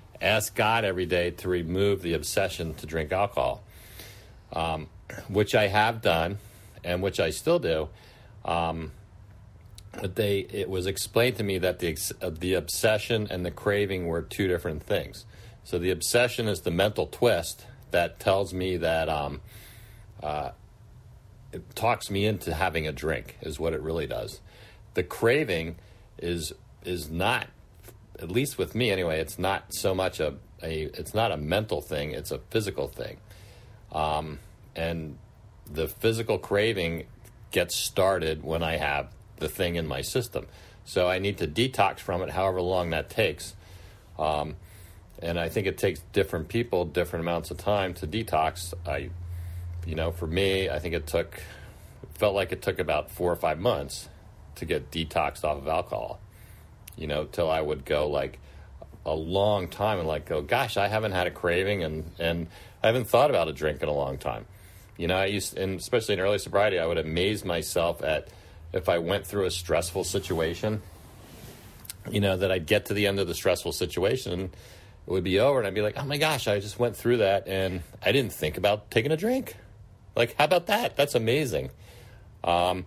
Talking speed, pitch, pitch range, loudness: 185 wpm, 95 Hz, 85-105 Hz, -28 LUFS